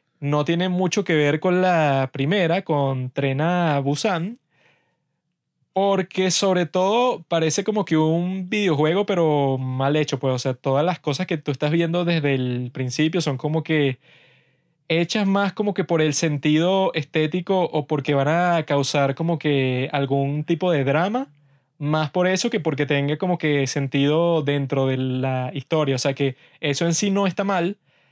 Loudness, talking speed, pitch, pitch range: -21 LUFS, 170 wpm, 155 Hz, 140-180 Hz